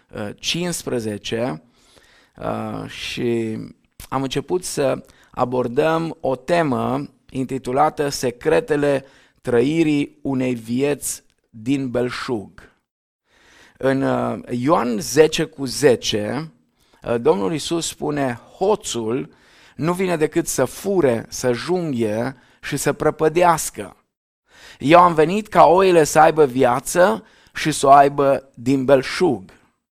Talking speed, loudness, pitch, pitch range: 95 wpm, -19 LUFS, 140 Hz, 125-160 Hz